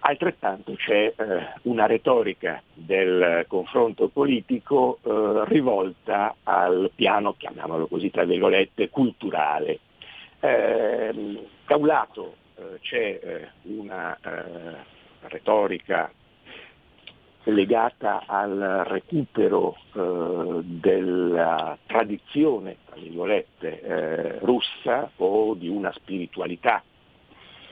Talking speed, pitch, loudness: 70 wpm, 255 Hz, -24 LUFS